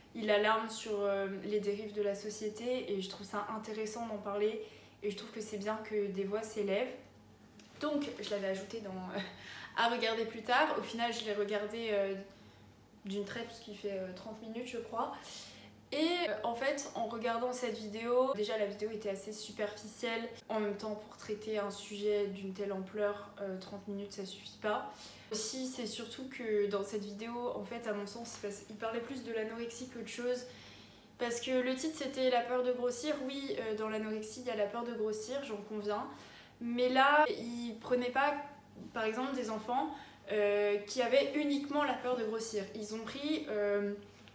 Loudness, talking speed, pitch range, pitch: -37 LUFS, 190 wpm, 205-240 Hz, 220 Hz